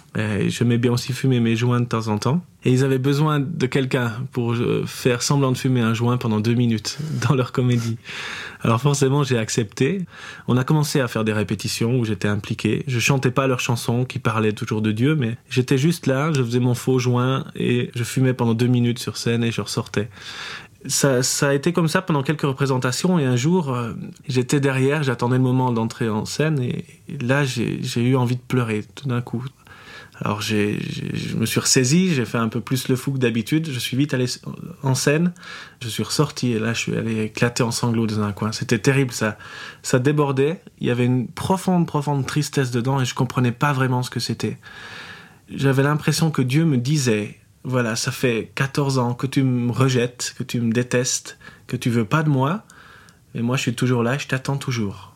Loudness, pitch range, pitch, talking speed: -21 LUFS, 120-140 Hz, 130 Hz, 215 wpm